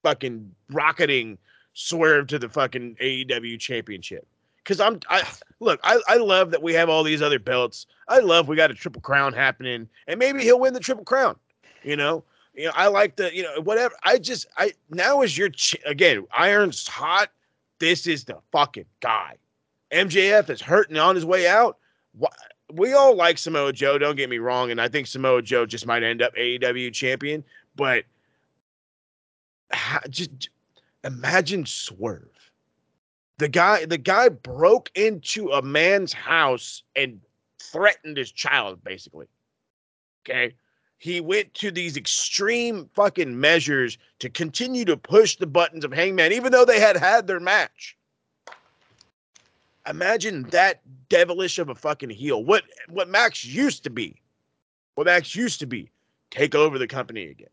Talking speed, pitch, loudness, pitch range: 160 wpm, 165 Hz, -21 LUFS, 135-205 Hz